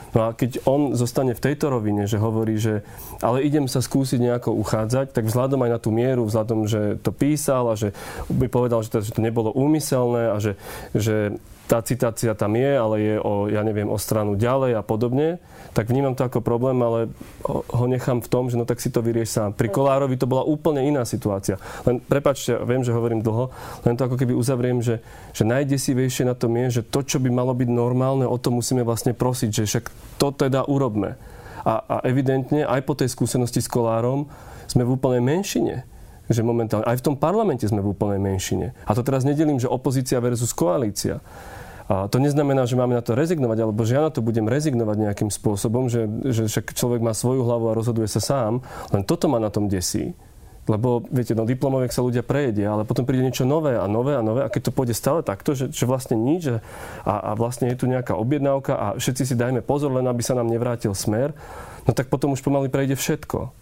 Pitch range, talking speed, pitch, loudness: 115-135 Hz, 215 wpm, 125 Hz, -22 LUFS